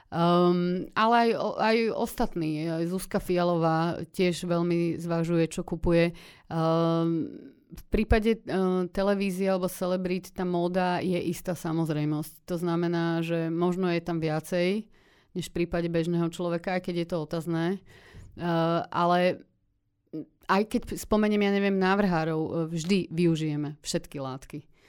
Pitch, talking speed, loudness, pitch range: 175 Hz, 130 wpm, -27 LUFS, 165-185 Hz